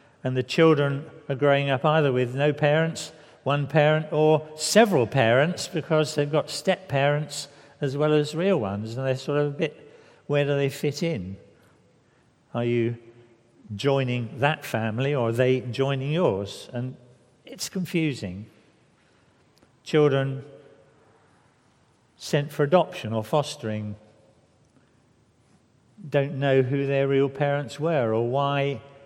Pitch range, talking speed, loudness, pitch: 125-150 Hz, 130 wpm, -24 LUFS, 140 Hz